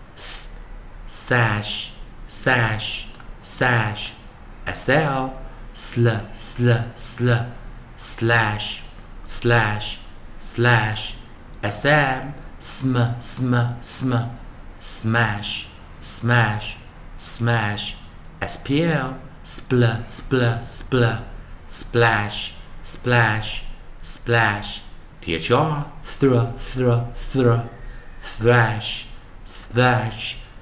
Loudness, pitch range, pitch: -19 LUFS, 105-120 Hz, 115 Hz